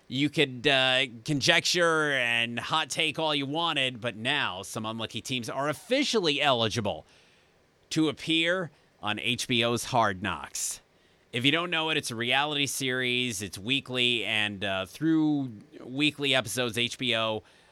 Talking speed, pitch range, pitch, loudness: 140 wpm, 115-150 Hz, 130 Hz, -27 LUFS